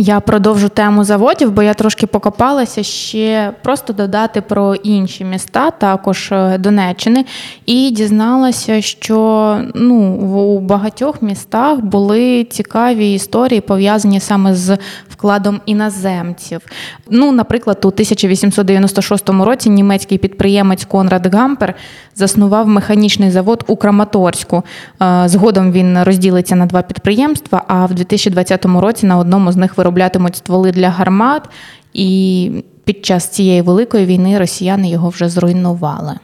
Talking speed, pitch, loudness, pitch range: 120 wpm, 200 Hz, -12 LUFS, 190-215 Hz